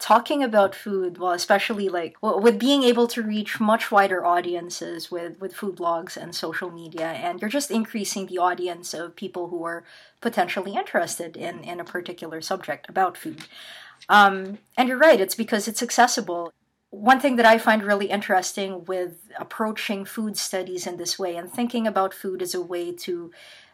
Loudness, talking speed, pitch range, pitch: -23 LUFS, 180 wpm, 175-220 Hz, 190 Hz